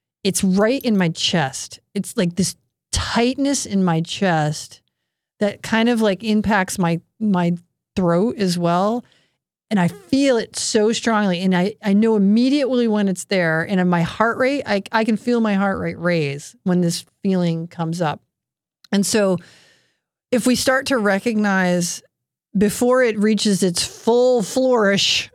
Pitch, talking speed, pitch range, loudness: 200 Hz, 160 wpm, 175-225 Hz, -19 LUFS